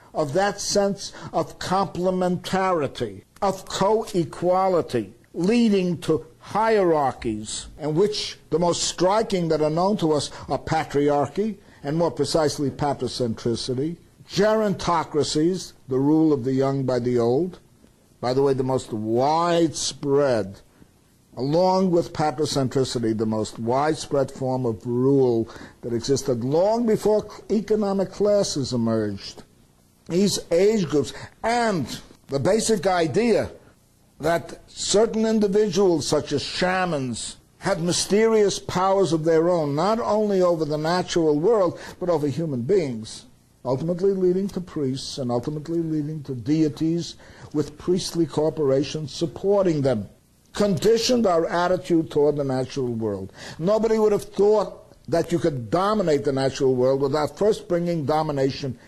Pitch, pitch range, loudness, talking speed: 155 Hz, 135-185 Hz, -23 LUFS, 125 wpm